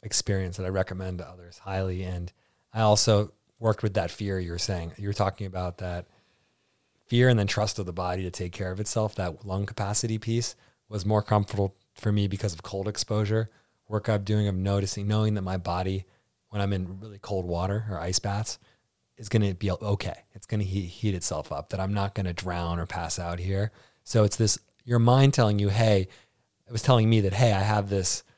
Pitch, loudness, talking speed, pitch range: 100 Hz, -27 LUFS, 220 wpm, 95-110 Hz